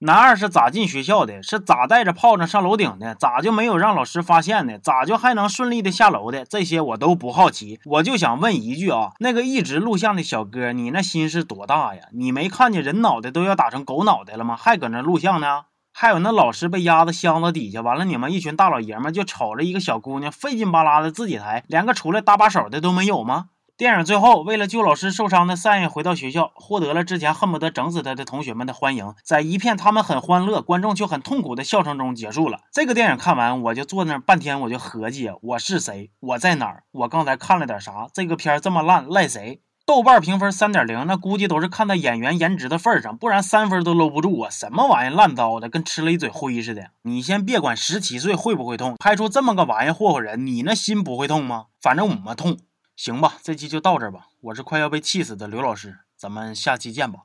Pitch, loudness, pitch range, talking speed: 175 Hz, -19 LUFS, 140-205 Hz, 360 characters per minute